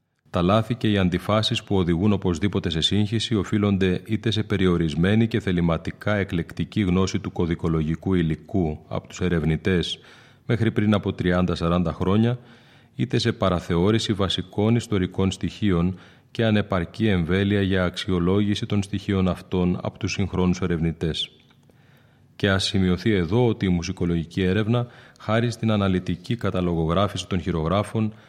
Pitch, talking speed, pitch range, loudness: 95 Hz, 130 wpm, 90-110 Hz, -23 LUFS